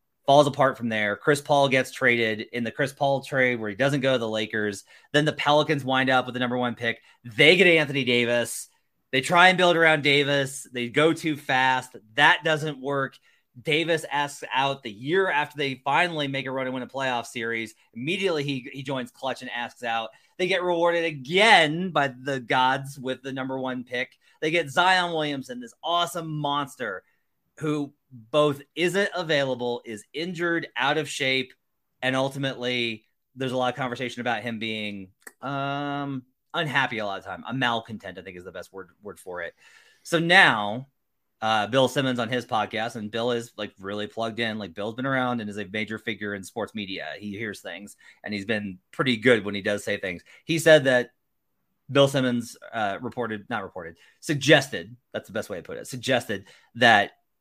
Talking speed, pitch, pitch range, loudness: 195 wpm, 130 Hz, 115-145 Hz, -24 LUFS